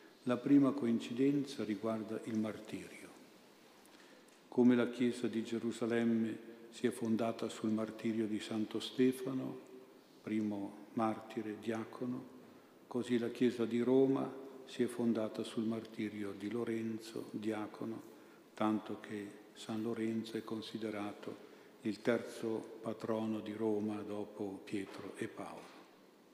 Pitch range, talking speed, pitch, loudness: 110-120 Hz, 115 wpm, 110 Hz, -38 LUFS